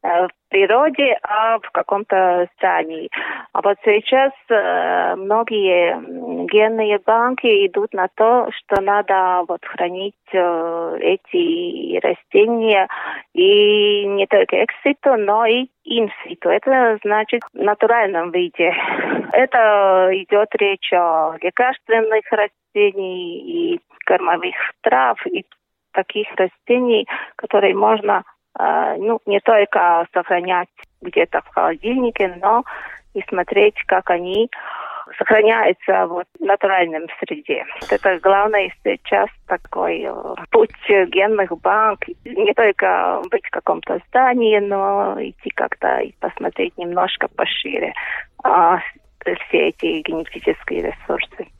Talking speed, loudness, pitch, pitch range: 110 wpm, -17 LUFS, 215 Hz, 190-280 Hz